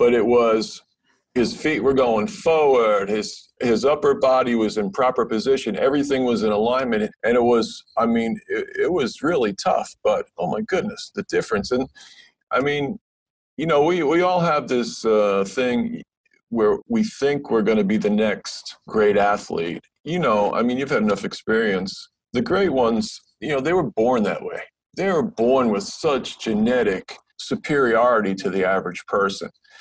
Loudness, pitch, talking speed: -21 LUFS, 140 Hz, 175 wpm